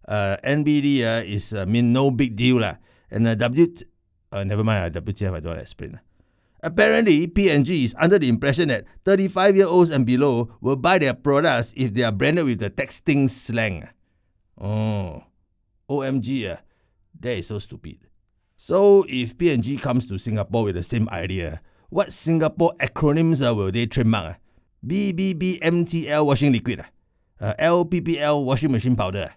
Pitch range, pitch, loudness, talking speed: 100-150 Hz, 120 Hz, -21 LUFS, 165 wpm